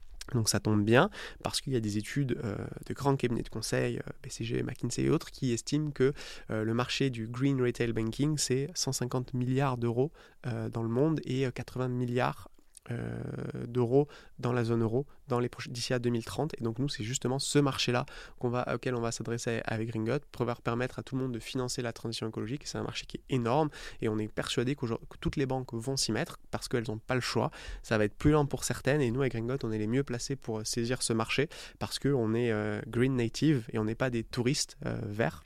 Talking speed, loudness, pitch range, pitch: 230 wpm, -32 LUFS, 115-135 Hz, 125 Hz